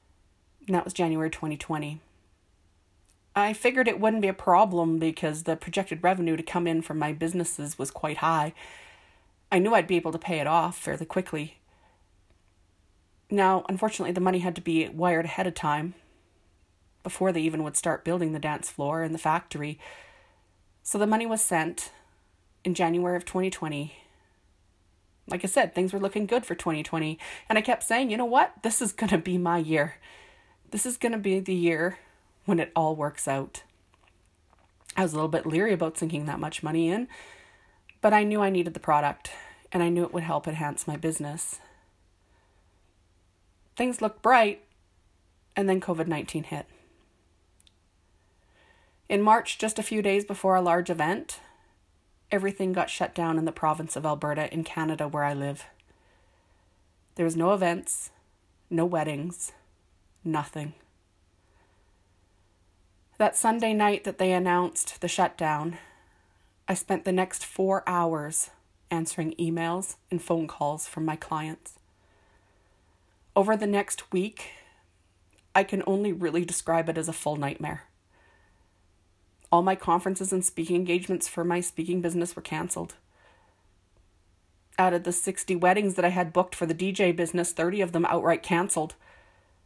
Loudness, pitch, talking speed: -27 LUFS, 165 Hz, 160 wpm